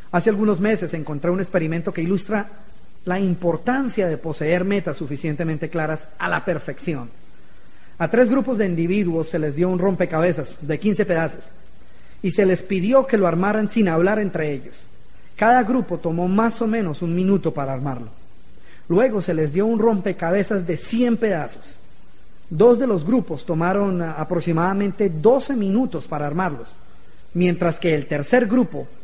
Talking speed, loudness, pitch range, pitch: 155 wpm, -21 LUFS, 165-210 Hz, 180 Hz